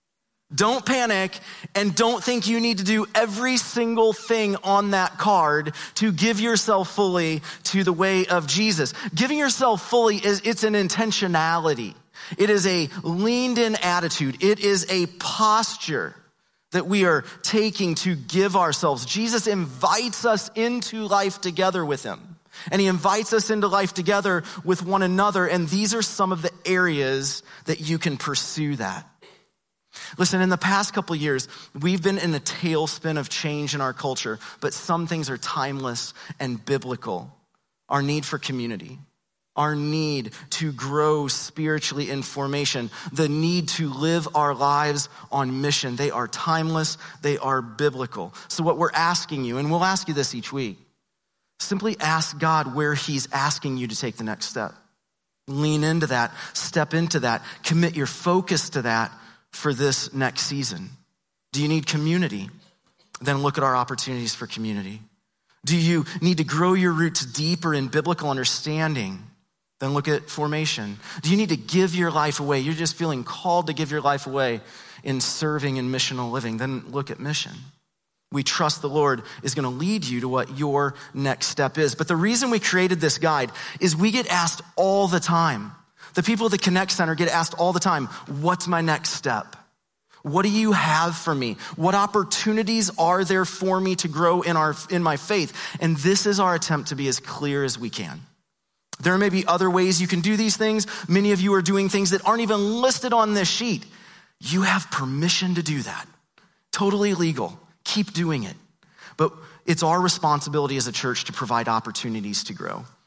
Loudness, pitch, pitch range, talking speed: -23 LUFS, 165 Hz, 145-190 Hz, 180 wpm